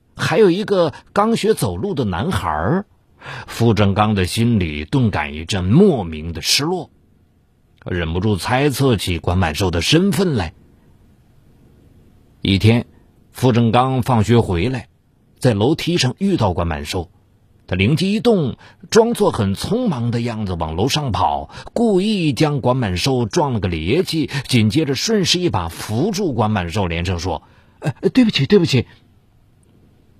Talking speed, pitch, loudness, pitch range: 215 characters per minute, 115 Hz, -18 LUFS, 95-145 Hz